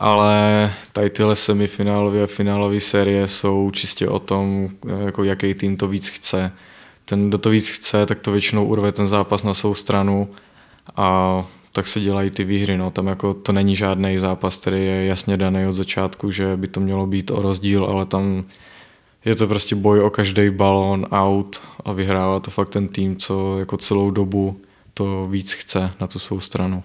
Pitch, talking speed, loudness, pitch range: 100 Hz, 190 wpm, -19 LUFS, 95-100 Hz